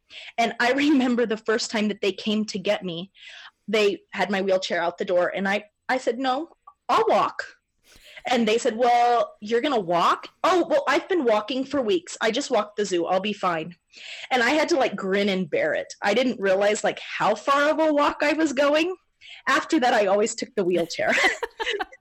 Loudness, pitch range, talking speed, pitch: -23 LUFS, 200-295 Hz, 205 wpm, 235 Hz